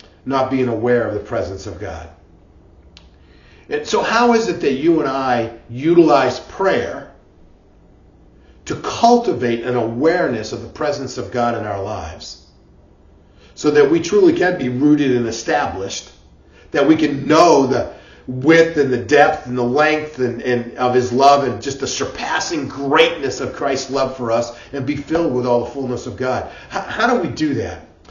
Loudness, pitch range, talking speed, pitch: -17 LUFS, 105-145 Hz, 175 wpm, 125 Hz